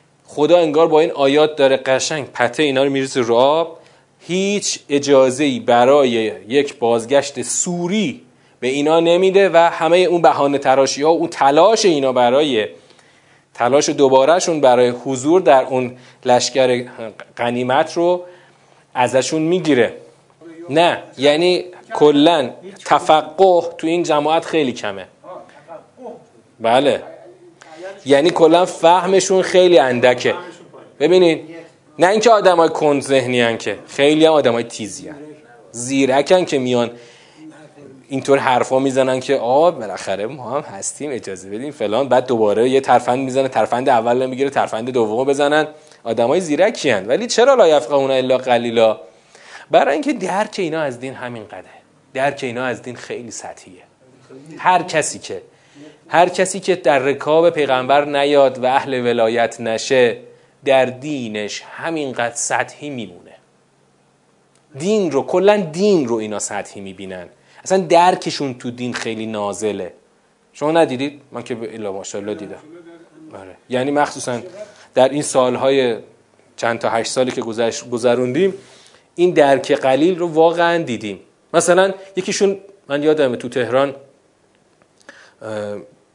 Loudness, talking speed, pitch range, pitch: -16 LUFS, 130 wpm, 125-165 Hz, 140 Hz